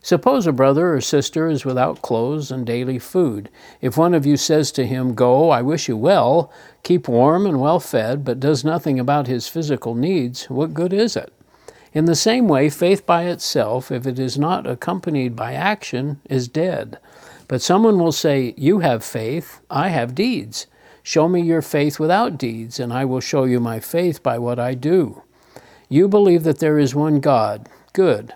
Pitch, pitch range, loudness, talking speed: 145 Hz, 130-170 Hz, -18 LUFS, 190 wpm